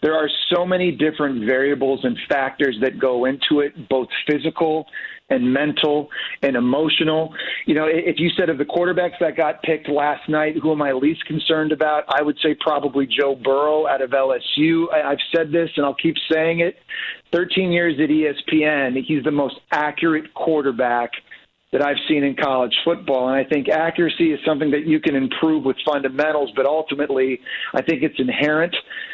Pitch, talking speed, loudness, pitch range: 155 Hz, 180 wpm, -19 LUFS, 140-160 Hz